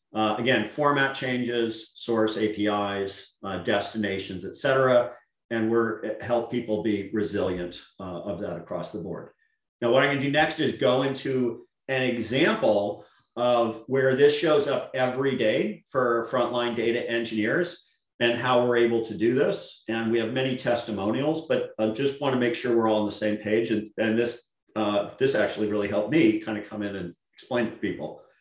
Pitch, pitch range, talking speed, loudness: 115 Hz, 110-130 Hz, 185 wpm, -26 LUFS